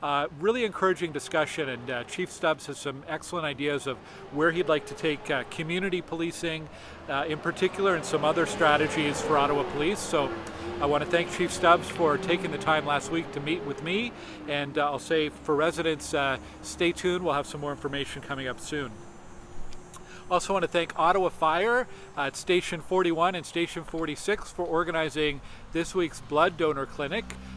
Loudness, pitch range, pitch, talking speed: -28 LUFS, 145-175 Hz, 160 Hz, 185 wpm